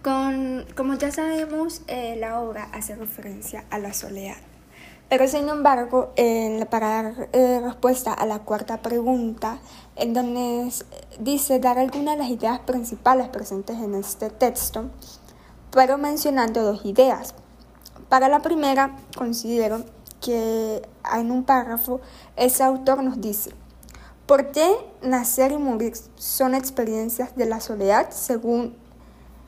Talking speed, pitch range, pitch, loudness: 130 wpm, 225-265 Hz, 245 Hz, -23 LUFS